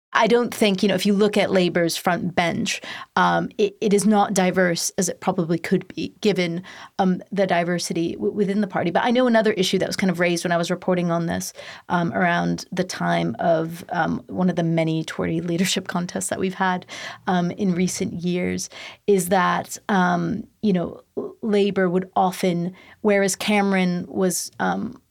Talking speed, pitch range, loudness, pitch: 190 wpm, 175-200 Hz, -22 LUFS, 185 Hz